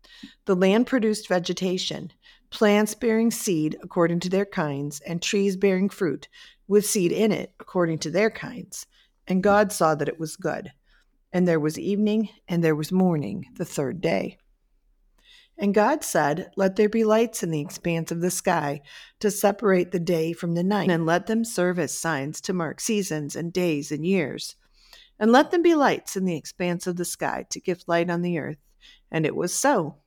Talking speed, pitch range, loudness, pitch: 190 wpm, 170-210 Hz, -24 LUFS, 185 Hz